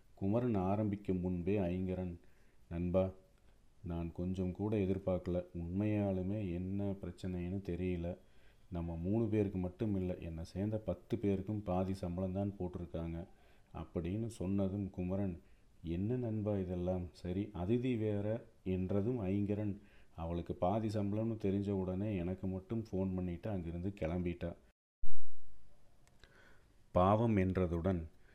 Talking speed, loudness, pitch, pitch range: 105 wpm, -38 LUFS, 95 Hz, 90-105 Hz